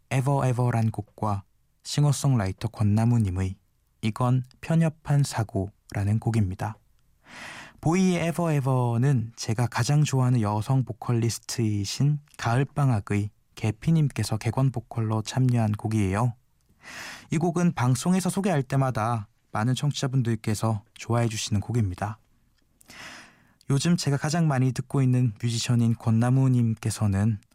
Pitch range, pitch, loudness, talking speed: 110-135 Hz, 120 Hz, -26 LUFS, 295 characters per minute